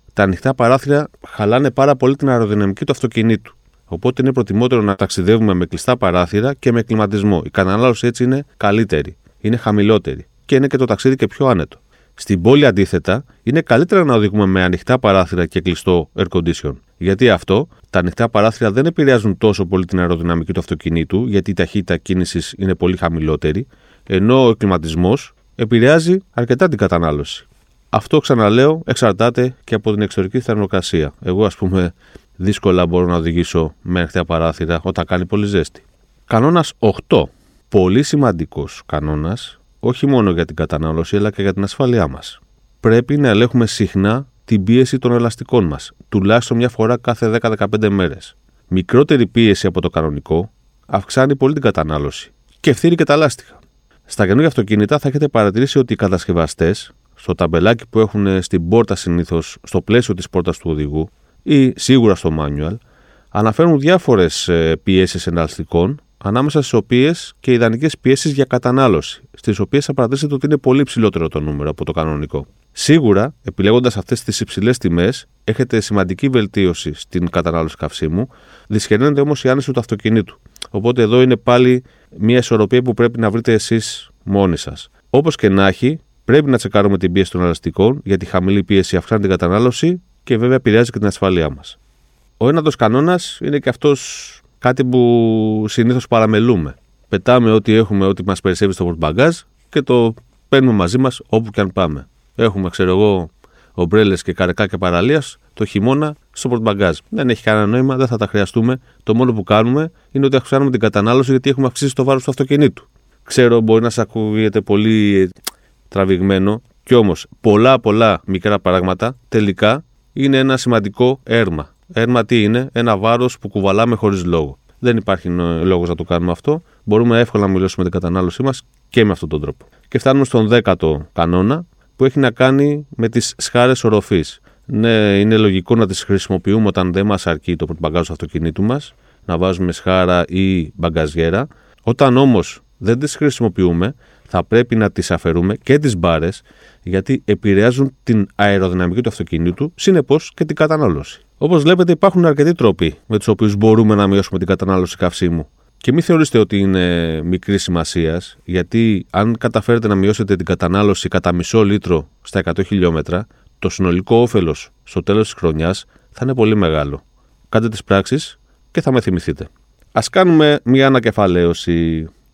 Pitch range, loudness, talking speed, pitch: 90-125 Hz, -15 LUFS, 165 wpm, 105 Hz